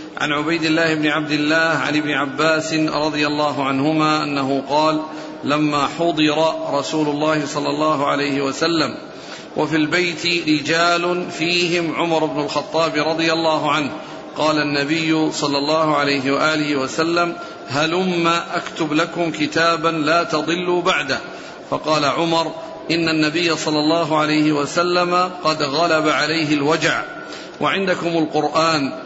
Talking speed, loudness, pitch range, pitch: 125 wpm, -18 LUFS, 150-165 Hz, 155 Hz